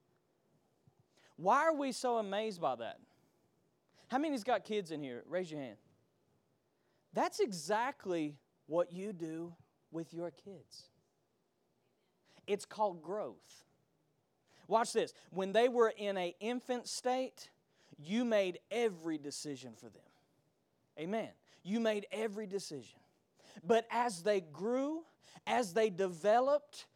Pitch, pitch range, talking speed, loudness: 200 Hz, 165-230 Hz, 120 wpm, -37 LUFS